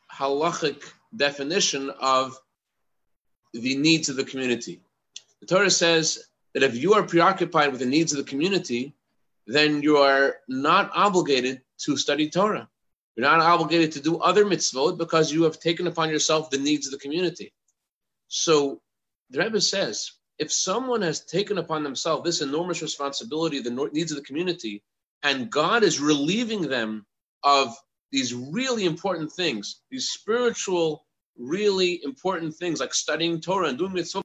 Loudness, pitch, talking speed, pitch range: -23 LUFS, 160 Hz, 150 wpm, 140-180 Hz